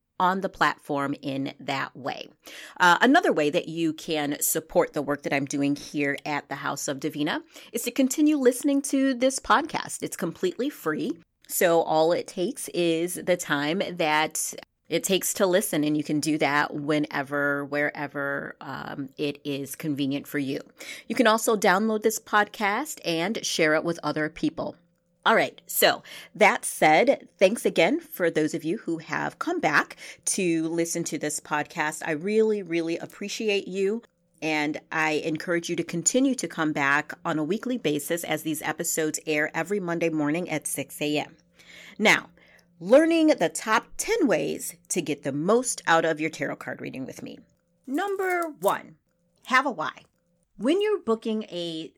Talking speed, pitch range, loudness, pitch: 170 wpm, 150-210 Hz, -25 LUFS, 170 Hz